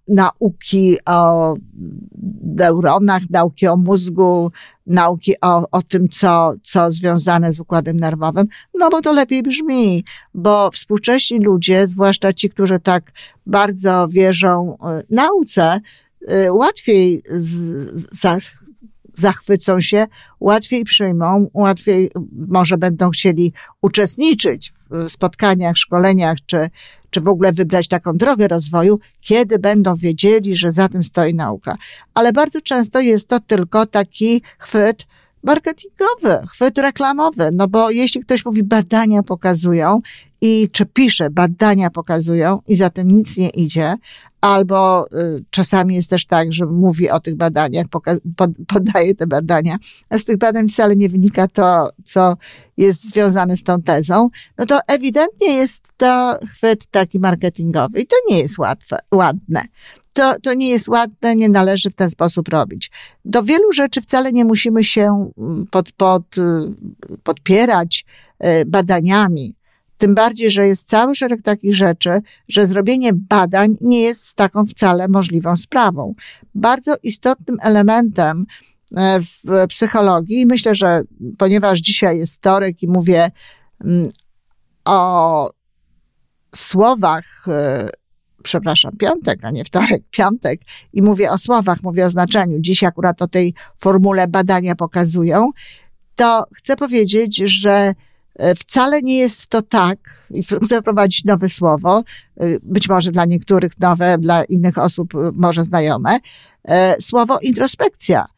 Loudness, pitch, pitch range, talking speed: -15 LUFS, 190 Hz, 175-220 Hz, 130 wpm